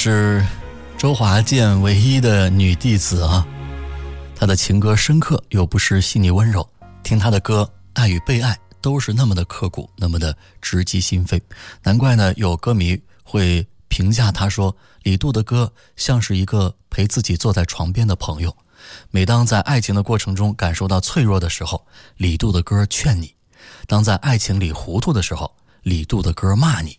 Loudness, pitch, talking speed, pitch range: -18 LUFS, 100 Hz, 255 characters per minute, 90-110 Hz